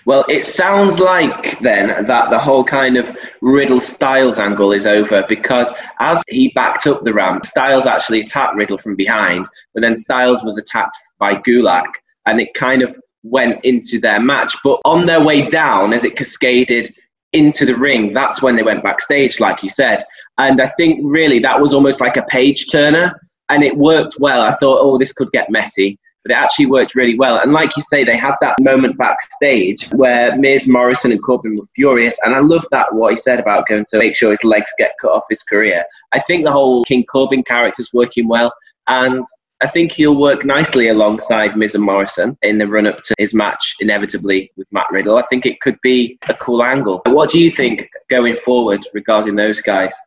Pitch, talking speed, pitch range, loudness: 125 Hz, 210 wpm, 110-145 Hz, -13 LUFS